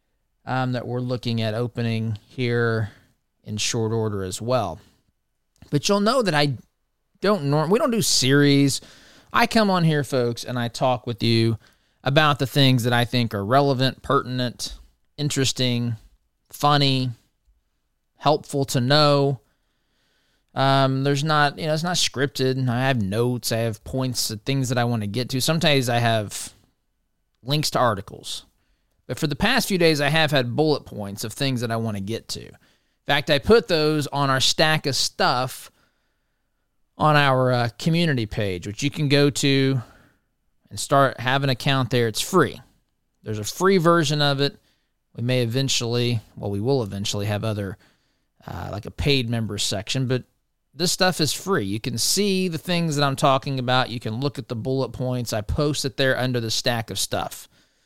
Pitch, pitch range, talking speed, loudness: 130 Hz, 115-145 Hz, 180 wpm, -22 LUFS